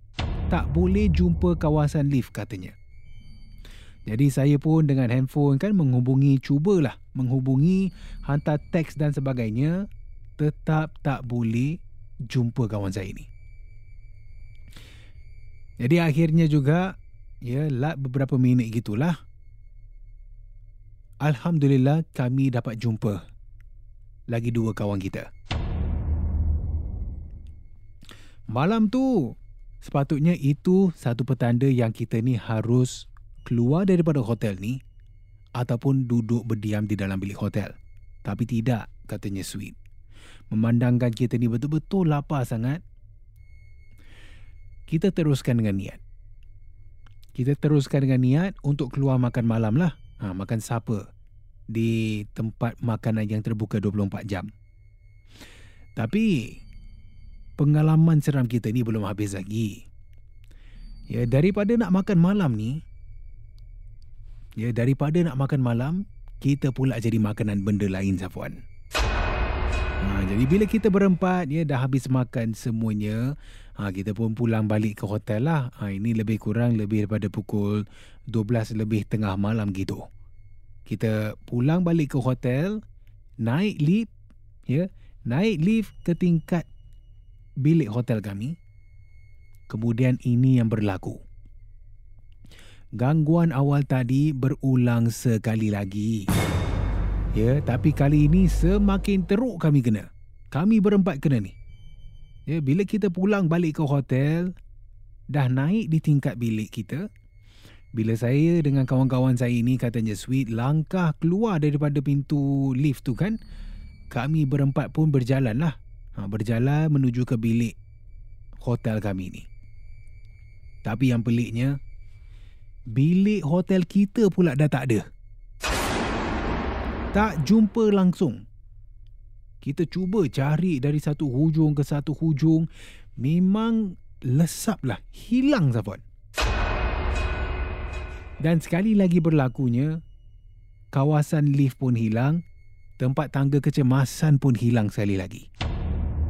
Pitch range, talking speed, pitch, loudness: 105-145 Hz, 110 wpm, 115 Hz, -24 LUFS